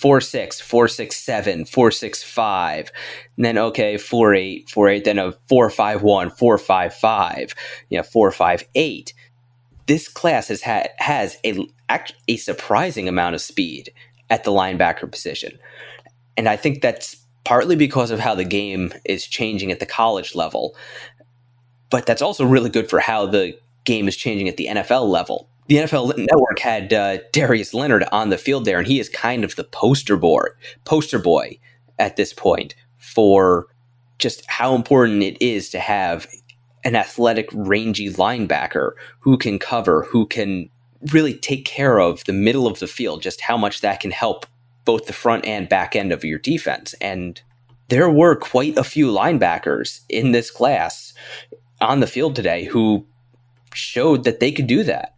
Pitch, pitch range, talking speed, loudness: 120 Hz, 100-125 Hz, 165 wpm, -18 LUFS